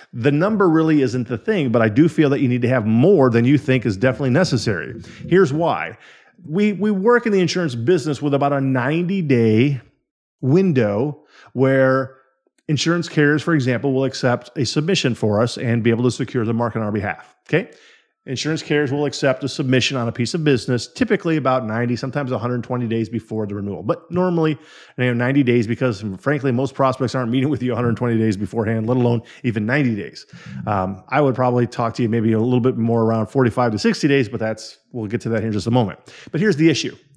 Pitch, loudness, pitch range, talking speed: 130 Hz, -19 LUFS, 115-150 Hz, 225 wpm